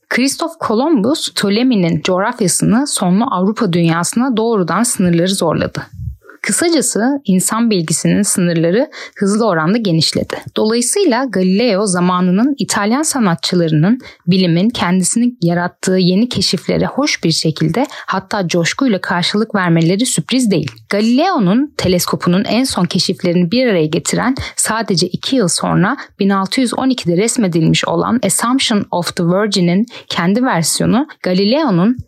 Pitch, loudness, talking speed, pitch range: 200 Hz, -14 LUFS, 110 wpm, 180-240 Hz